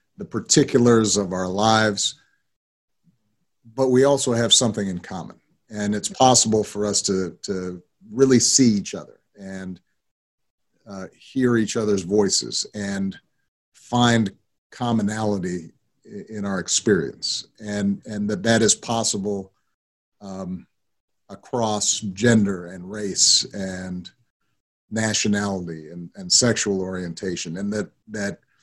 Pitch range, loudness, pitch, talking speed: 95-120 Hz, -21 LUFS, 105 Hz, 115 wpm